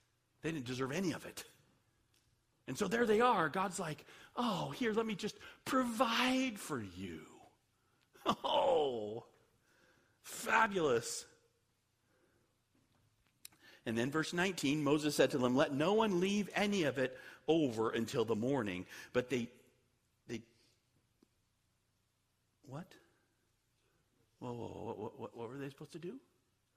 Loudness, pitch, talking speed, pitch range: -36 LUFS, 130 Hz, 125 wpm, 115-190 Hz